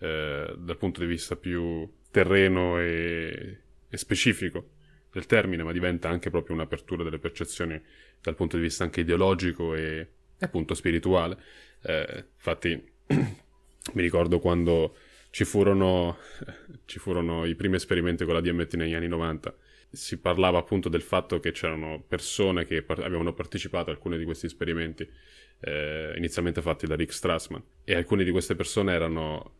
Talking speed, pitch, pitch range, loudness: 150 wpm, 85 Hz, 80-90 Hz, -28 LUFS